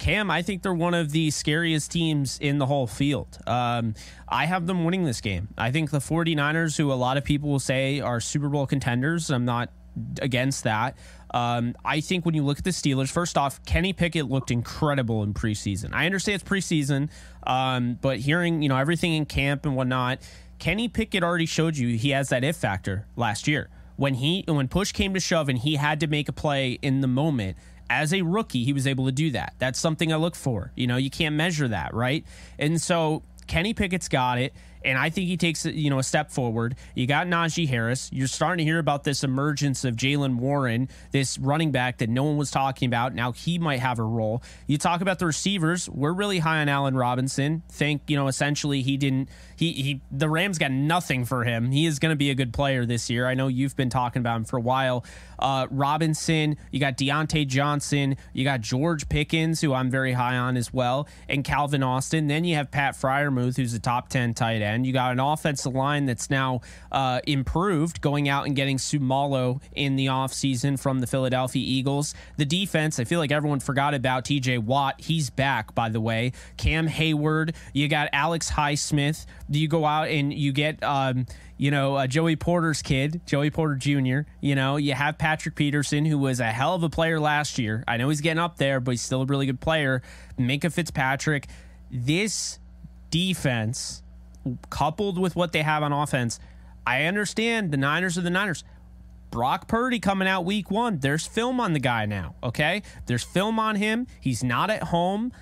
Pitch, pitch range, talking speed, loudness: 140 Hz, 130-160 Hz, 210 wpm, -25 LUFS